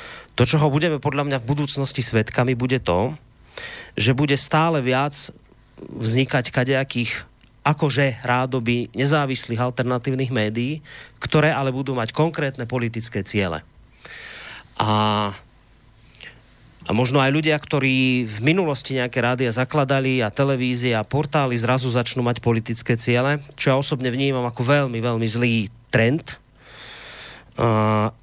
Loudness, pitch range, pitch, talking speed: -21 LUFS, 120-140 Hz, 125 Hz, 125 wpm